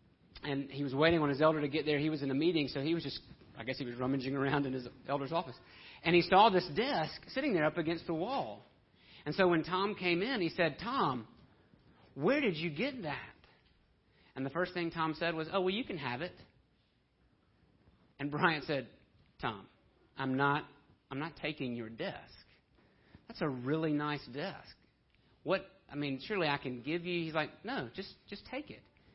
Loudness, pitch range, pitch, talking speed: -34 LUFS, 140-175 Hz, 155 Hz, 200 wpm